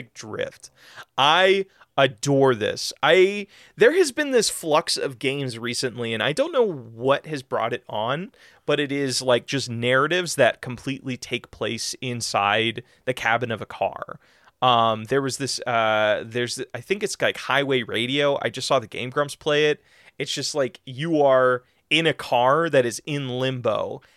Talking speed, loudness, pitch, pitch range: 175 wpm, -22 LUFS, 135 Hz, 120-150 Hz